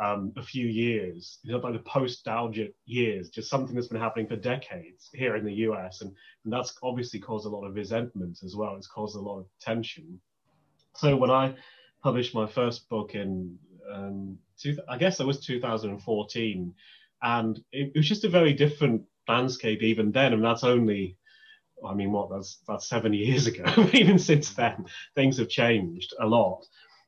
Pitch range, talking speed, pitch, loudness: 105-130 Hz, 190 wpm, 115 Hz, -27 LUFS